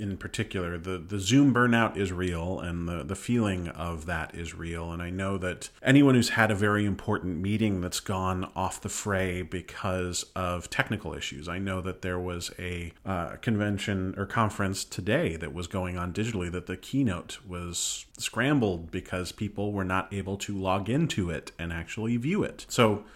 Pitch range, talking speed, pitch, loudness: 90-105 Hz, 185 wpm, 95 Hz, -29 LUFS